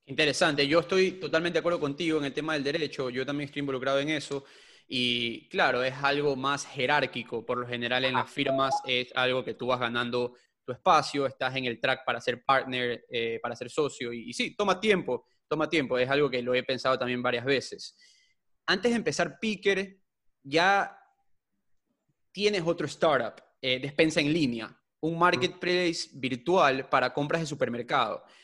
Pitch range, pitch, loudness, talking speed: 125-170 Hz, 140 Hz, -28 LUFS, 175 wpm